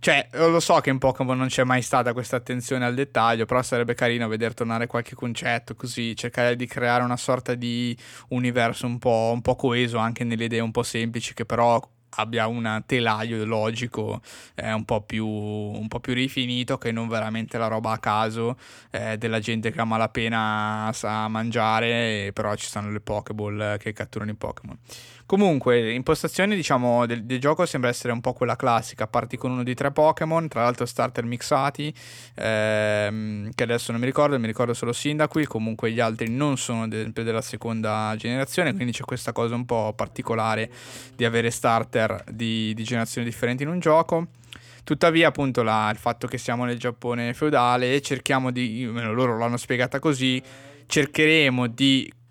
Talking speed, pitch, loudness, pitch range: 180 wpm, 120 Hz, -24 LUFS, 115-130 Hz